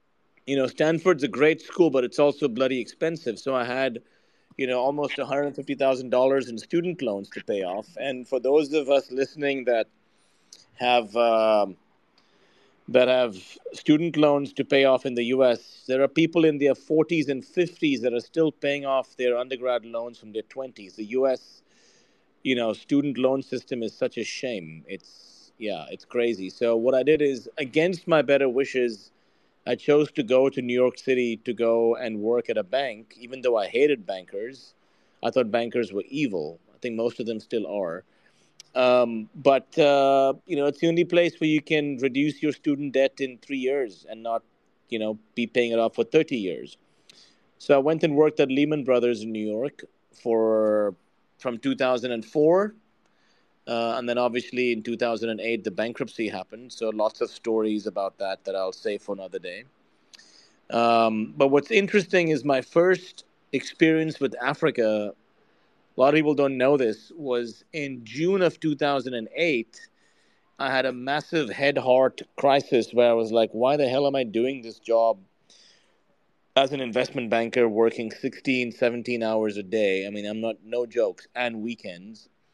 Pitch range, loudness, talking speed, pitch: 115-145 Hz, -24 LUFS, 175 wpm, 130 Hz